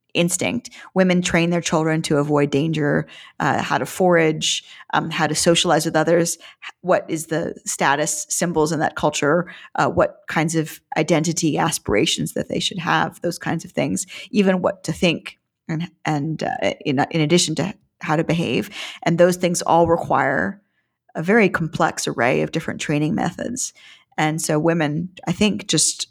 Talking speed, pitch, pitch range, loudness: 170 wpm, 165 Hz, 155-175 Hz, -20 LUFS